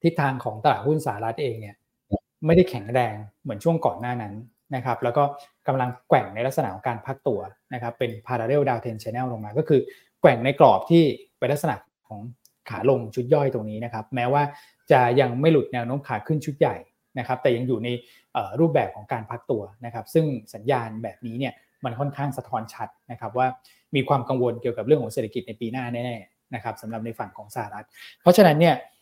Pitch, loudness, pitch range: 125 Hz, -24 LUFS, 115-140 Hz